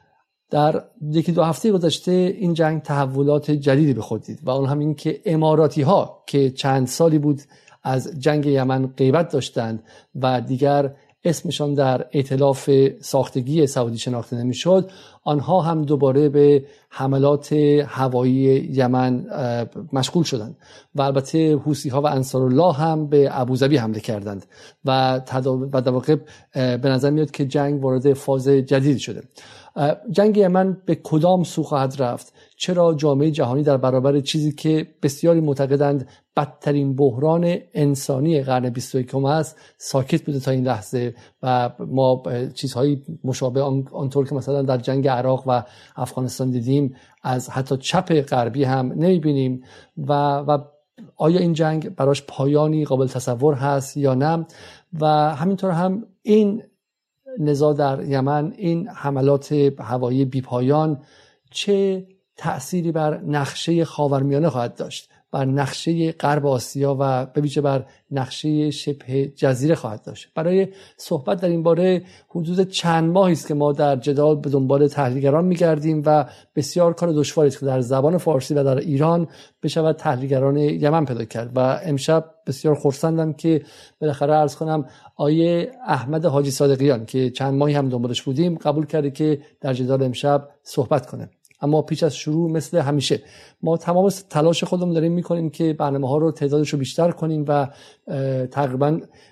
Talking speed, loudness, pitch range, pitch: 145 wpm, -20 LUFS, 135-160 Hz, 145 Hz